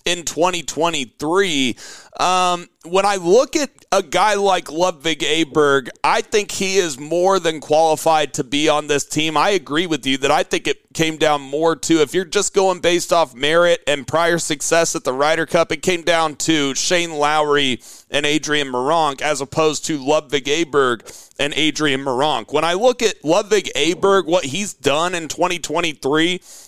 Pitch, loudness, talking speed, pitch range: 165 Hz, -18 LUFS, 175 wpm, 150-180 Hz